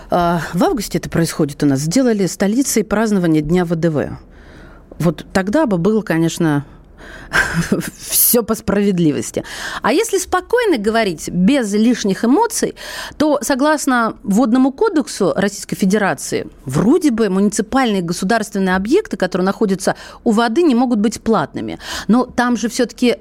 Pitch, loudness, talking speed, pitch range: 210 Hz, -16 LUFS, 125 wpm, 175-245 Hz